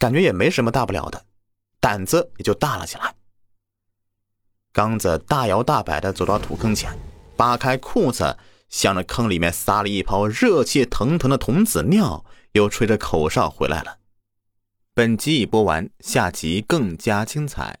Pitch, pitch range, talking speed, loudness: 100 Hz, 100-110 Hz, 235 characters per minute, -20 LUFS